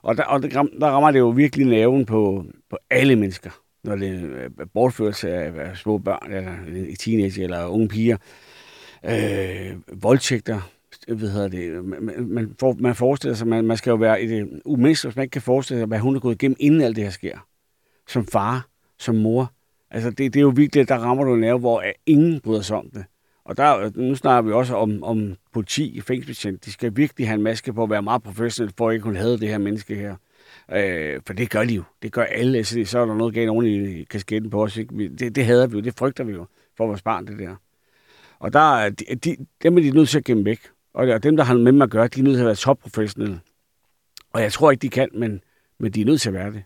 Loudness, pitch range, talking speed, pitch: -20 LUFS, 105-130 Hz, 245 wpm, 115 Hz